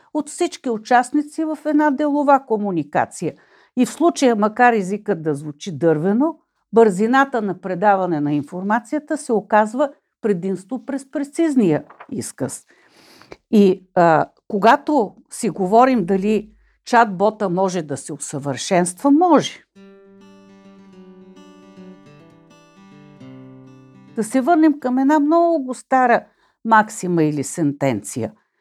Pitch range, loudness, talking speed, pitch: 180-270 Hz, -18 LUFS, 100 wpm, 210 Hz